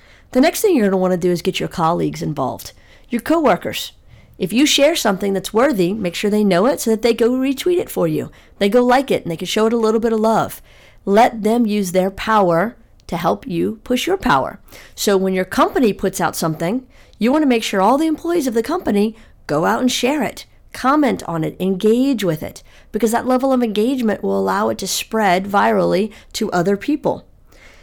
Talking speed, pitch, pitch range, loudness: 220 wpm, 220 Hz, 190-250 Hz, -17 LUFS